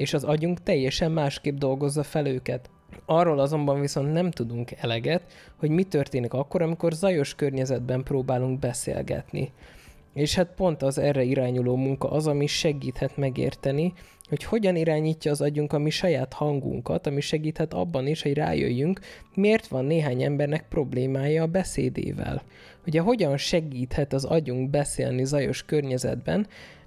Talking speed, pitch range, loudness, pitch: 145 wpm, 135-160 Hz, -26 LUFS, 145 Hz